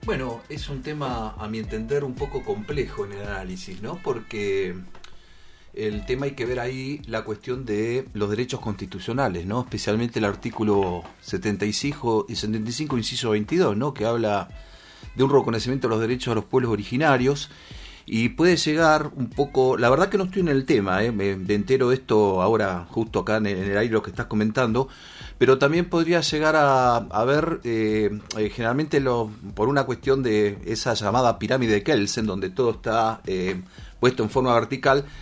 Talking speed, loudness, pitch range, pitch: 180 wpm, -23 LUFS, 105-130 Hz, 115 Hz